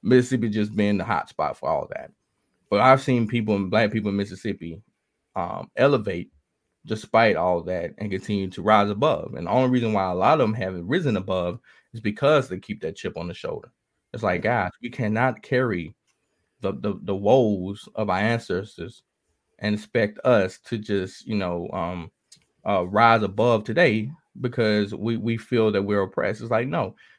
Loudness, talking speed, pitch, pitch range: -23 LUFS, 185 wpm, 105 Hz, 95-115 Hz